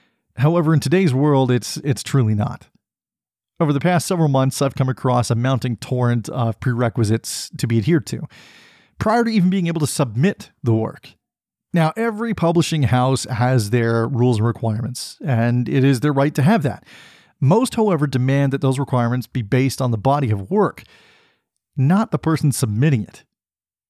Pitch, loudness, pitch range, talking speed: 135 Hz, -19 LUFS, 120-155 Hz, 175 wpm